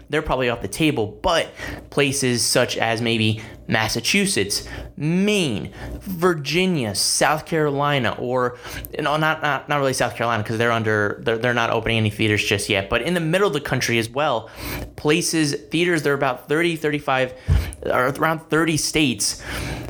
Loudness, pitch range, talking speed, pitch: -21 LUFS, 115-155 Hz, 165 wpm, 130 Hz